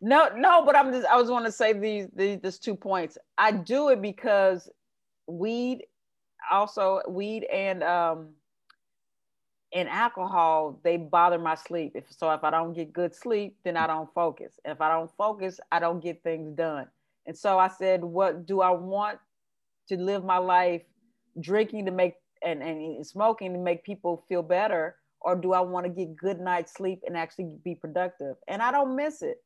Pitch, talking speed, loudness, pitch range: 185 Hz, 190 wpm, -27 LUFS, 170-205 Hz